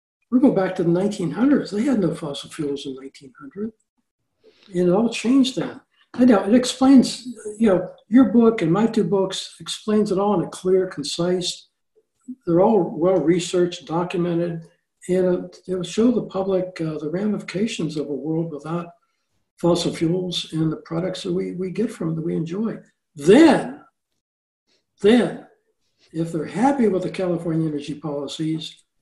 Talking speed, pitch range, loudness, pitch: 165 wpm, 165-220 Hz, -21 LUFS, 185 Hz